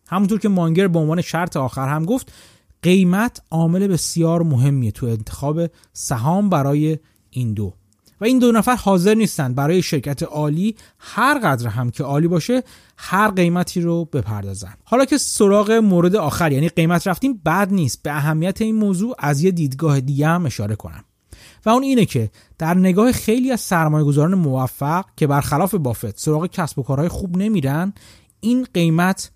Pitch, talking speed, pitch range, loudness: 165 Hz, 165 wpm, 140-195 Hz, -18 LUFS